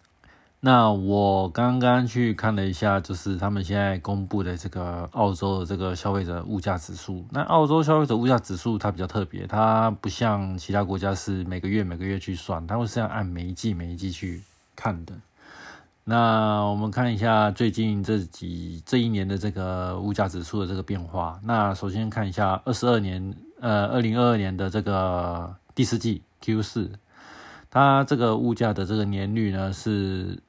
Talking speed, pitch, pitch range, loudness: 275 characters per minute, 100 Hz, 95-110 Hz, -25 LUFS